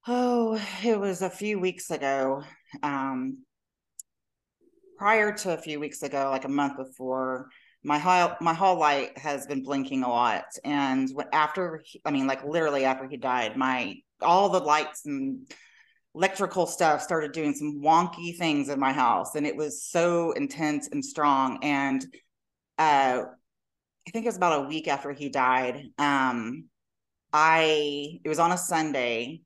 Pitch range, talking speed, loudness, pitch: 135-180 Hz, 160 wpm, -26 LUFS, 150 Hz